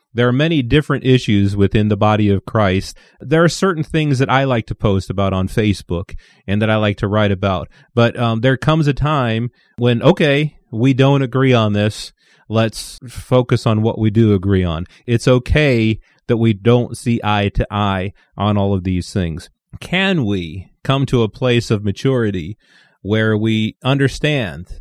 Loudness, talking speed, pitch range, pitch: -16 LUFS, 180 wpm, 100-130 Hz, 115 Hz